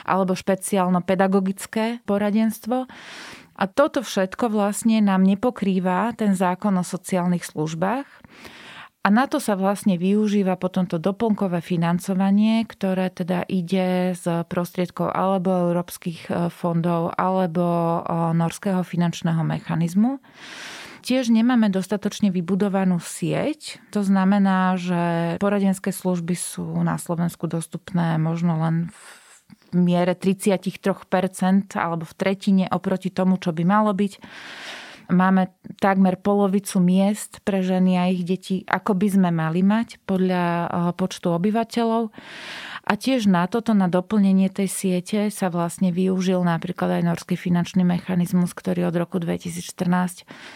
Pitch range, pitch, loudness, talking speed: 175-205 Hz, 185 Hz, -22 LUFS, 120 wpm